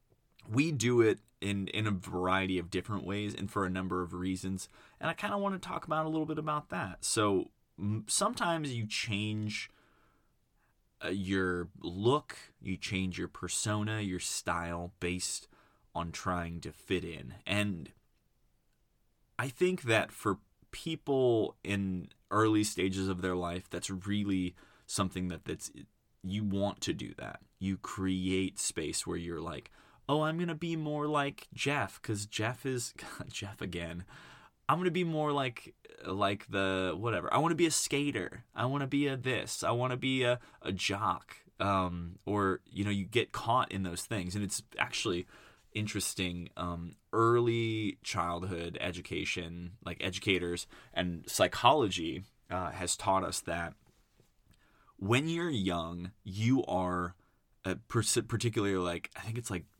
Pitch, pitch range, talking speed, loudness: 100 Hz, 90-120 Hz, 160 wpm, -34 LUFS